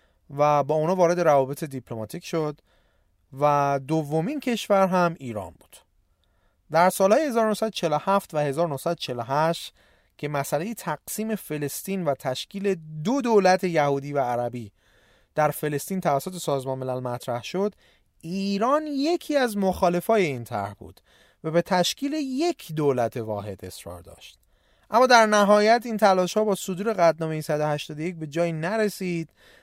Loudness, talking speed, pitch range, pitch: -24 LUFS, 130 wpm, 130-195 Hz, 160 Hz